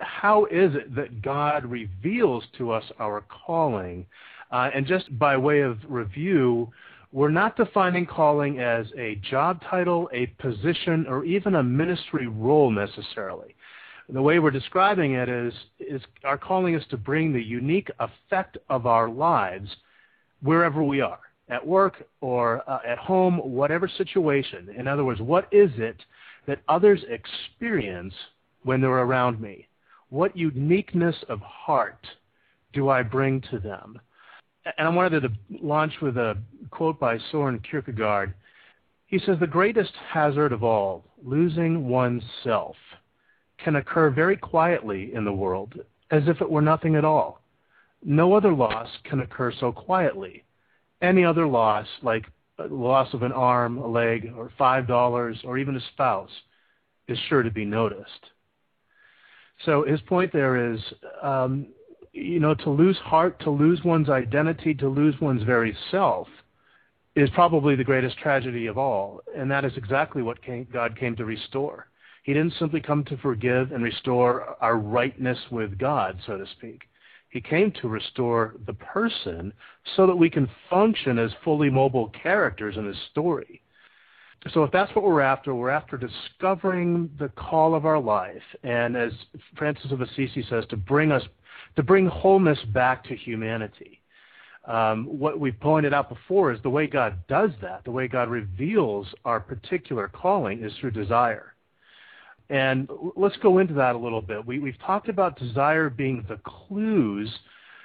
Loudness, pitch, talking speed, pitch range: -24 LUFS, 135 Hz, 160 wpm, 120-160 Hz